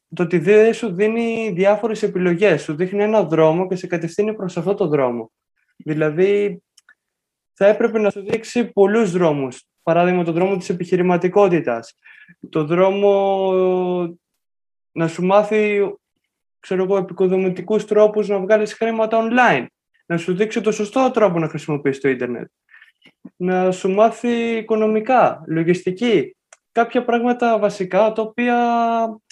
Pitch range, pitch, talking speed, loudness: 180-220 Hz, 200 Hz, 125 wpm, -18 LUFS